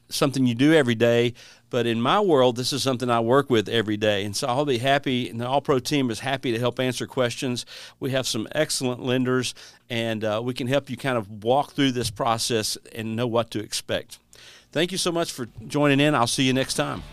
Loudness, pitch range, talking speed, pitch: -23 LUFS, 115-135 Hz, 235 wpm, 125 Hz